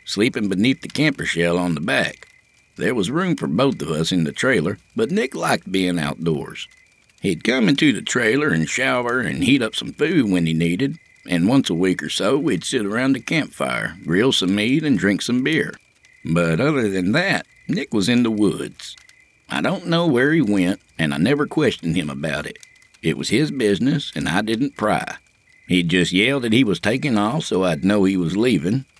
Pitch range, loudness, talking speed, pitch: 85-125 Hz, -20 LUFS, 205 wpm, 95 Hz